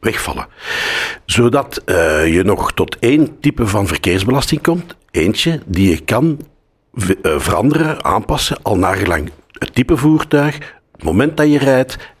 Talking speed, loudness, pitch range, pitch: 140 wpm, -15 LUFS, 95-150 Hz, 130 Hz